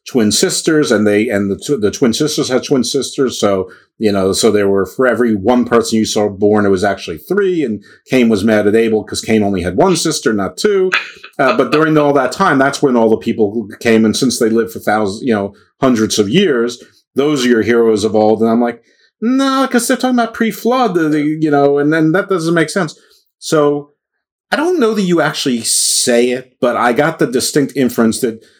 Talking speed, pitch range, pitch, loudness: 225 wpm, 110-160 Hz, 125 Hz, -13 LUFS